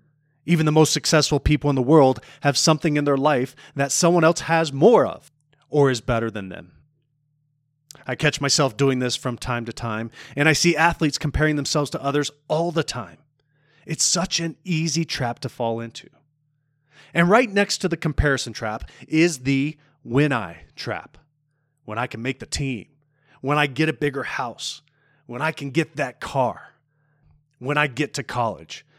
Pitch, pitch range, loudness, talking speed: 145 Hz, 135-155 Hz, -21 LUFS, 180 wpm